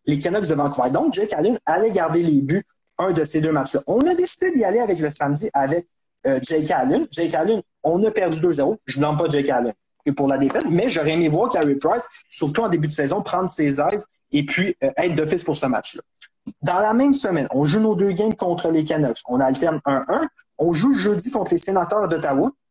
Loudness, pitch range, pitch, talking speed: -20 LUFS, 145-210 Hz, 165 Hz, 230 wpm